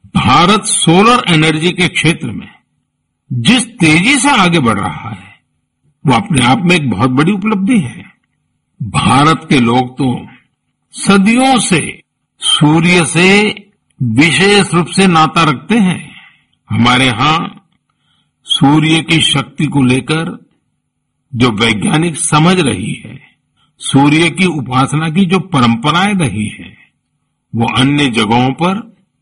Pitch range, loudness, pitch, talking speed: 135-190 Hz, -10 LUFS, 160 Hz, 125 wpm